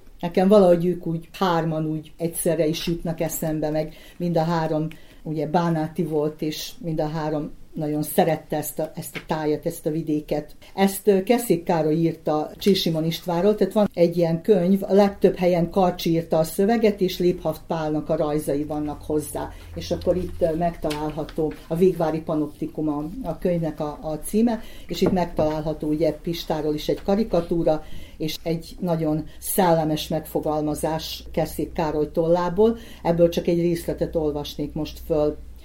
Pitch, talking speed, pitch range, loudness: 165 Hz, 155 wpm, 155-175 Hz, -23 LUFS